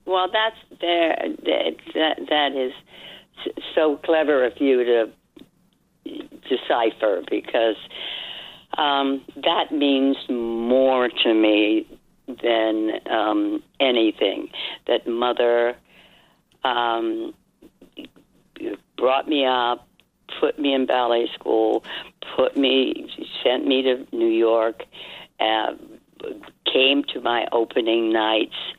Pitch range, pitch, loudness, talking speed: 115-160 Hz, 130 Hz, -21 LUFS, 100 wpm